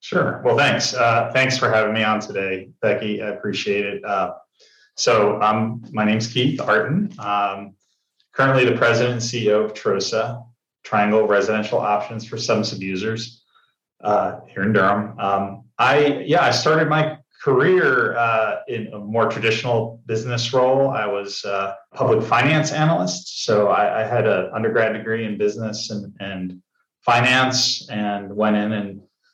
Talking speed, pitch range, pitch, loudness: 155 wpm, 105-125 Hz, 110 Hz, -20 LUFS